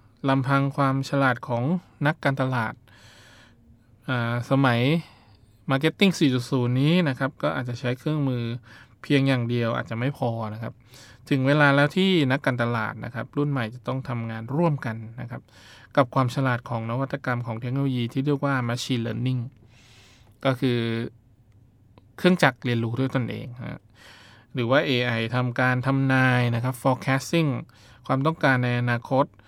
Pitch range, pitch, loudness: 115-135 Hz, 125 Hz, -24 LUFS